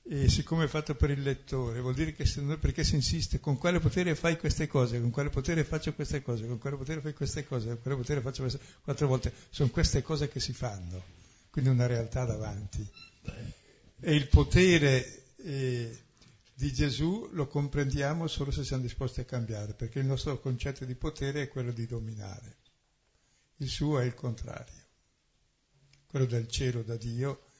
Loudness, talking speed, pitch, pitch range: -31 LUFS, 185 wpm, 135 Hz, 120-145 Hz